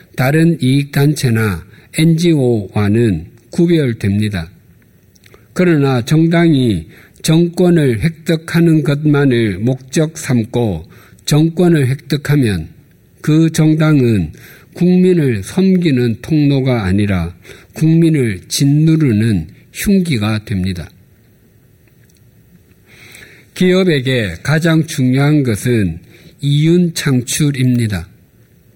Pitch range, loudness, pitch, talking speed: 110-160 Hz, -14 LUFS, 130 Hz, 190 characters per minute